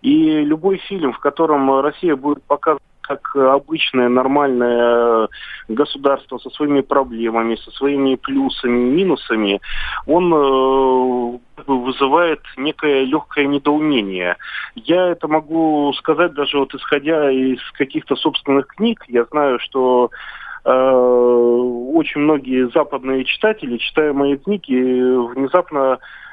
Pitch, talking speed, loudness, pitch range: 140 Hz, 110 wpm, -17 LUFS, 125-150 Hz